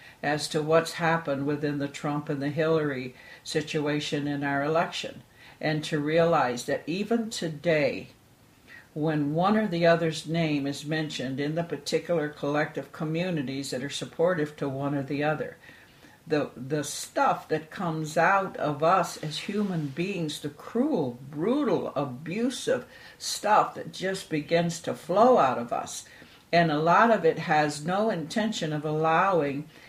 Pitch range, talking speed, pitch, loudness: 145-170 Hz, 150 wpm, 155 Hz, -27 LUFS